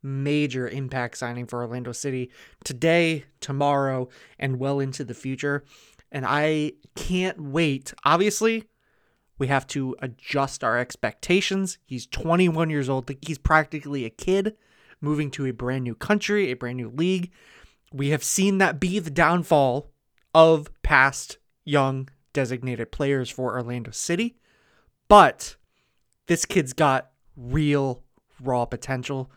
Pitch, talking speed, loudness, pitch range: 140 Hz, 130 wpm, -24 LUFS, 130-165 Hz